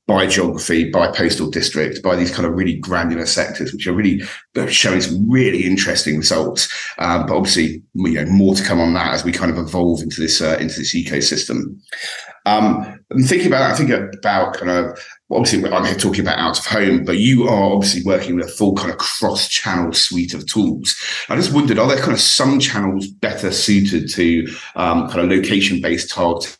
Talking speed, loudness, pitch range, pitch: 205 wpm, -16 LUFS, 85-100 Hz, 90 Hz